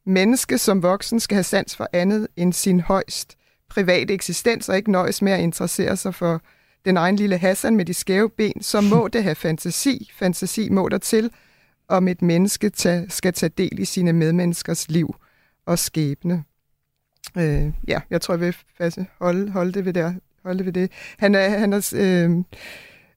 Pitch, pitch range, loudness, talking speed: 185 Hz, 175-200 Hz, -21 LUFS, 175 wpm